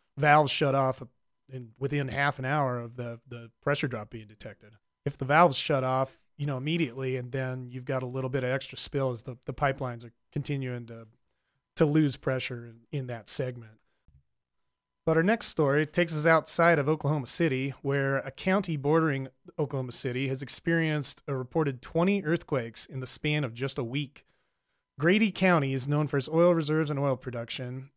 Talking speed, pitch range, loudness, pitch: 185 wpm, 125-150 Hz, -28 LUFS, 135 Hz